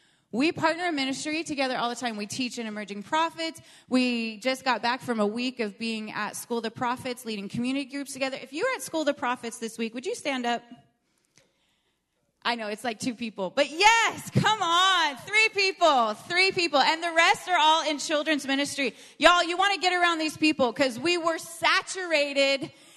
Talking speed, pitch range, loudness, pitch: 205 wpm, 240-330 Hz, -25 LUFS, 275 Hz